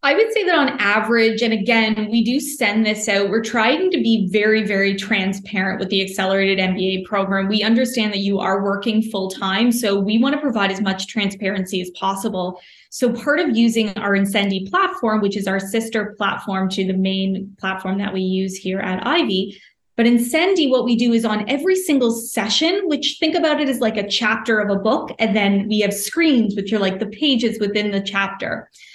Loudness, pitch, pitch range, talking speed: -19 LUFS, 215 Hz, 195-235 Hz, 205 wpm